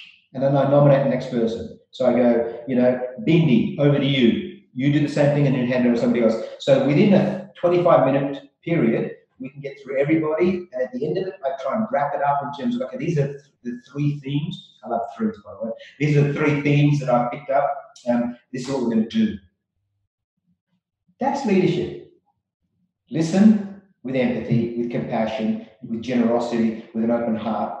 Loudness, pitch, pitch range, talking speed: -21 LUFS, 140 Hz, 120-175 Hz, 205 wpm